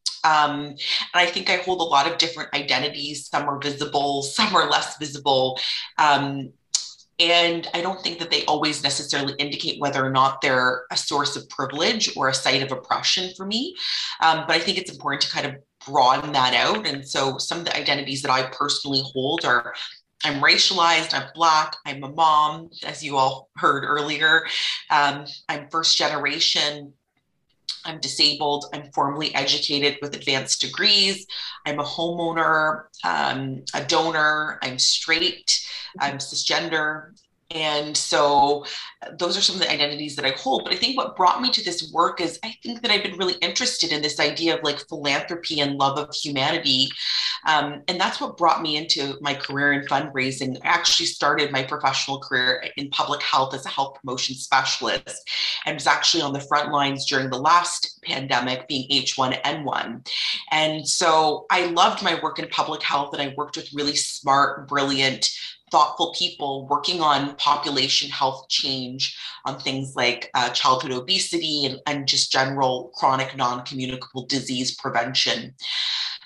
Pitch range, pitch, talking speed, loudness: 135-160 Hz, 145 Hz, 170 wpm, -21 LUFS